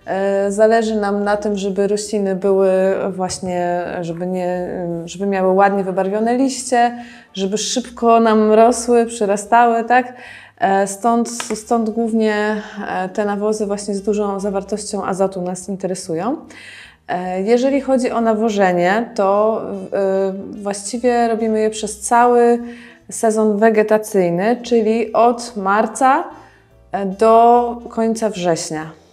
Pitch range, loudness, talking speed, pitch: 195-235 Hz, -17 LUFS, 105 wpm, 215 Hz